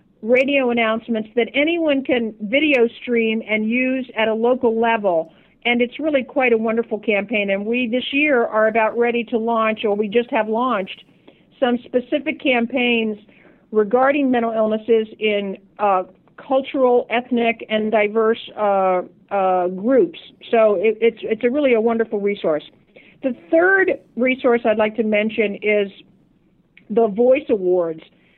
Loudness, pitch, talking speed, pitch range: -19 LUFS, 230 Hz, 145 wpm, 215-250 Hz